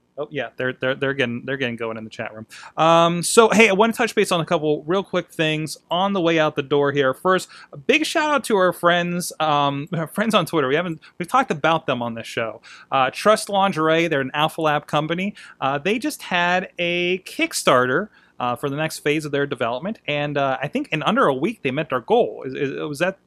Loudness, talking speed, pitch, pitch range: -20 LUFS, 245 wpm, 160 Hz, 140-190 Hz